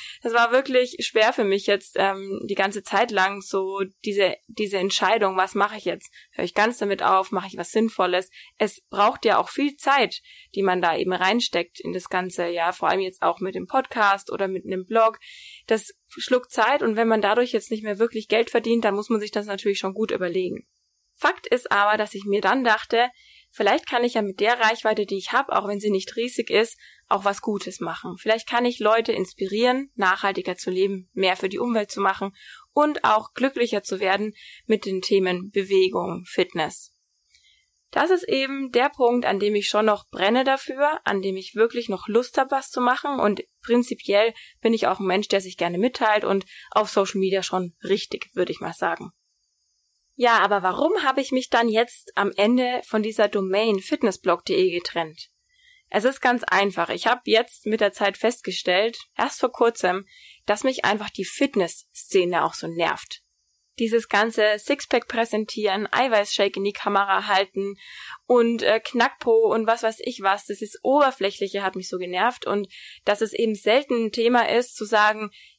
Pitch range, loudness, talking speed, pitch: 195-240 Hz, -23 LUFS, 195 wpm, 215 Hz